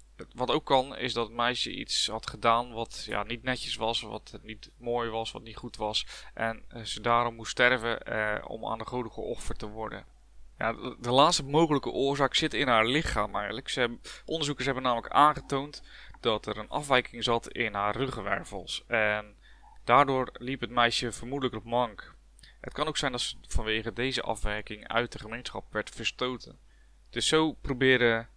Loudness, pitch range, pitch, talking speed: -29 LUFS, 110-130 Hz, 120 Hz, 180 wpm